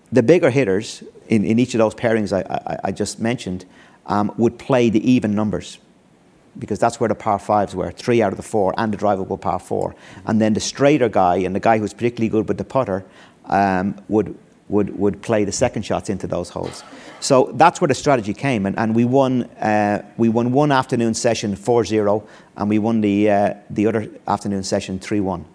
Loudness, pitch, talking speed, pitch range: -19 LUFS, 105 Hz, 215 wpm, 100-115 Hz